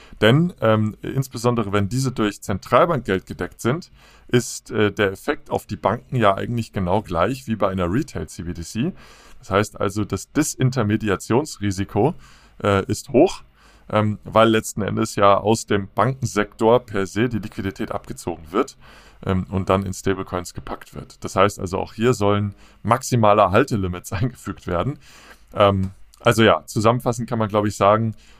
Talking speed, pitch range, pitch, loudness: 150 wpm, 100-120 Hz, 105 Hz, -21 LUFS